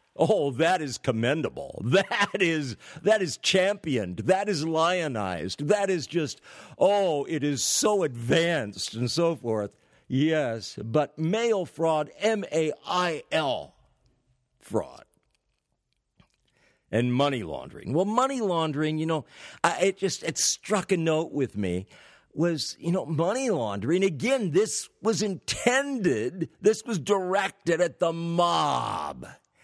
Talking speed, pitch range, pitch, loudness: 125 wpm, 140-195 Hz, 165 Hz, -26 LUFS